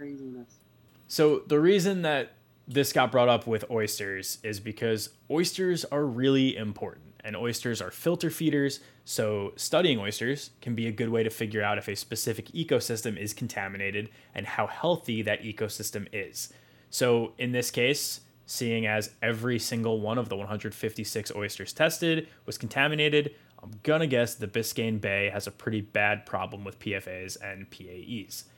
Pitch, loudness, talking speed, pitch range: 115 Hz, -29 LUFS, 155 wpm, 105-135 Hz